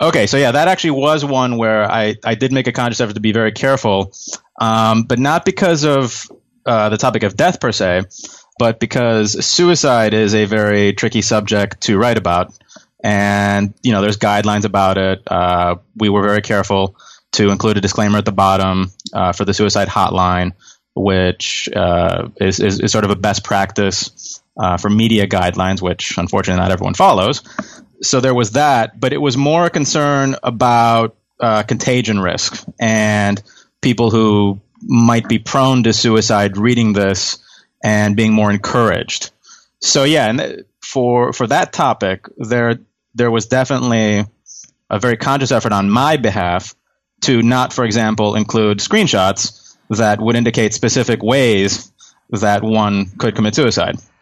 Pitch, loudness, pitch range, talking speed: 110 Hz, -15 LUFS, 100-120 Hz, 165 wpm